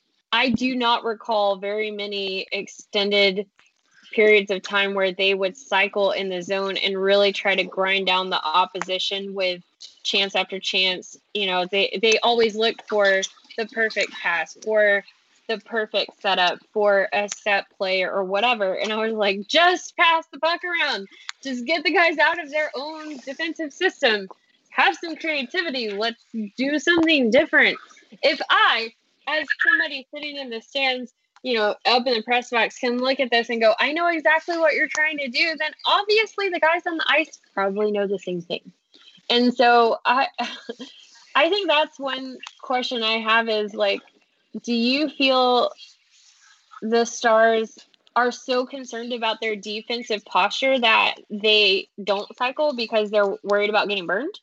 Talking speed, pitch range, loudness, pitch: 165 wpm, 200-290 Hz, -21 LUFS, 230 Hz